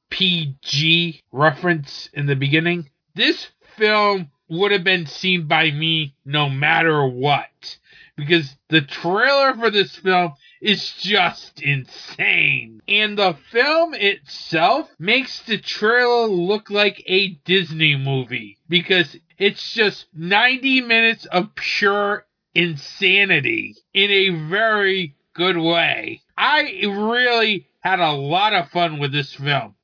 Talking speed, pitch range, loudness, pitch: 120 wpm, 155-205 Hz, -18 LUFS, 180 Hz